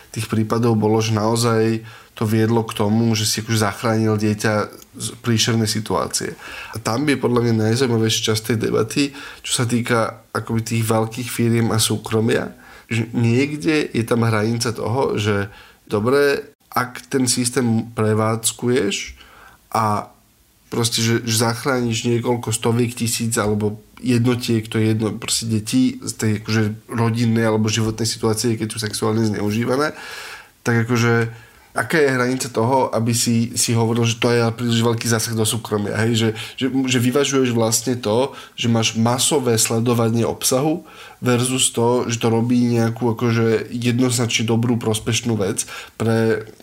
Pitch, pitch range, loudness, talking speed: 115 Hz, 110-120 Hz, -19 LUFS, 145 wpm